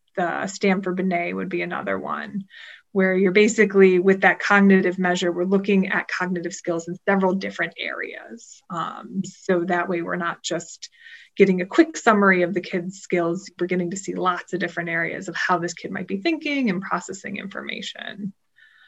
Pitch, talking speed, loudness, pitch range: 185 Hz, 180 wpm, -22 LUFS, 175-200 Hz